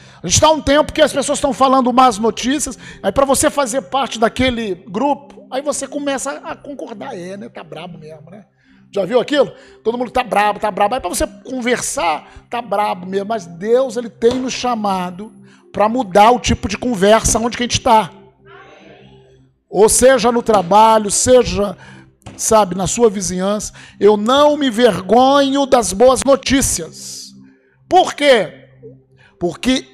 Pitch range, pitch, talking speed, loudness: 195-265 Hz, 230 Hz, 165 wpm, -15 LUFS